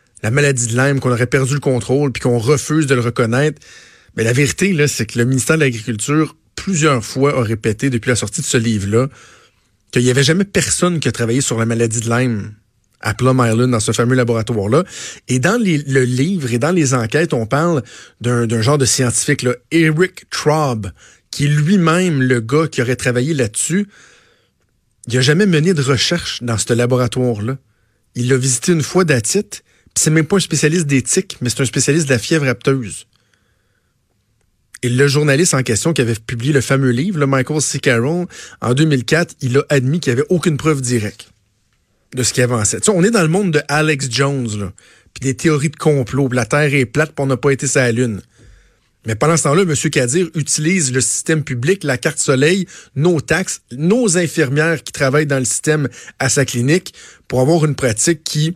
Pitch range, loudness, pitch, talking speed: 120-155 Hz, -15 LUFS, 135 Hz, 200 wpm